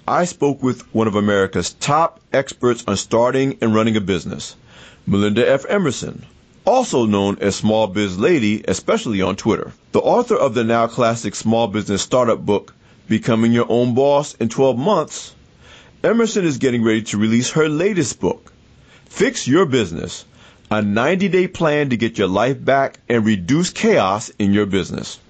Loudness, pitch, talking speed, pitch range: -18 LUFS, 115 Hz, 165 wpm, 105-135 Hz